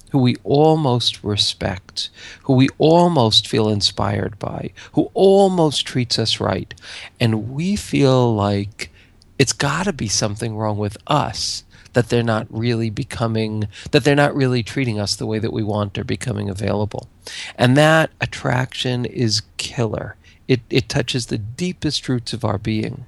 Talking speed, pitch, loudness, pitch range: 155 wpm, 115 Hz, -19 LUFS, 105-130 Hz